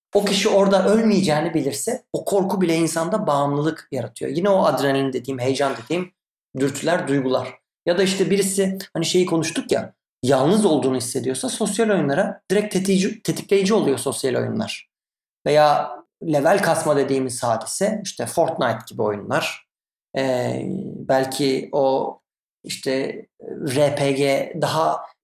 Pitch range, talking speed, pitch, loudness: 135-195 Hz, 125 wpm, 160 Hz, -21 LUFS